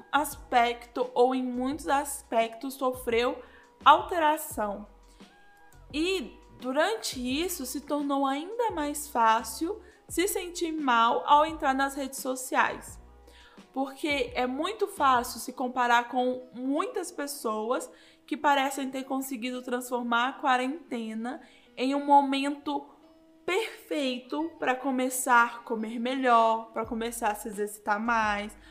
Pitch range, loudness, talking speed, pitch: 240-295 Hz, -28 LUFS, 115 wpm, 265 Hz